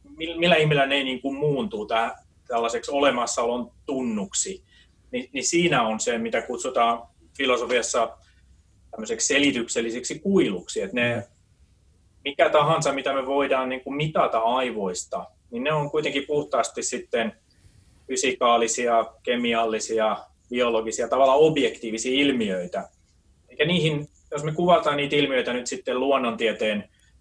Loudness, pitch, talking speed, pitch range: -24 LUFS, 130 Hz, 115 wpm, 115-150 Hz